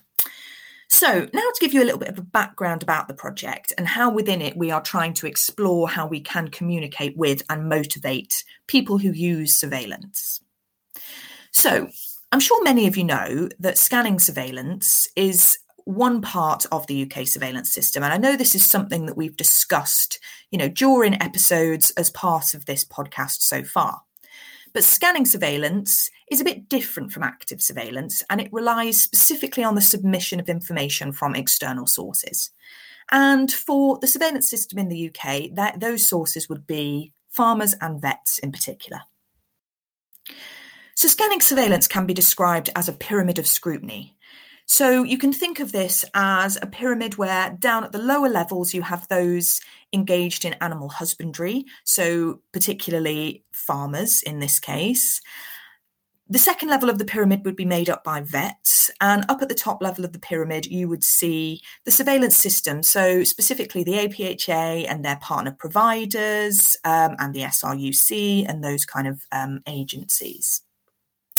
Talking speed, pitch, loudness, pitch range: 165 wpm, 185 Hz, -19 LUFS, 160-225 Hz